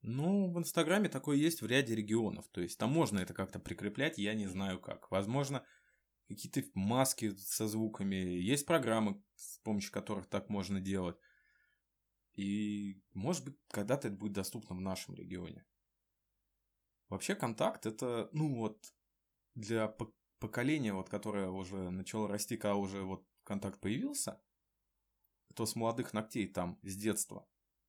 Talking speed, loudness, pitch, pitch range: 140 wpm, -37 LUFS, 105 Hz, 95-115 Hz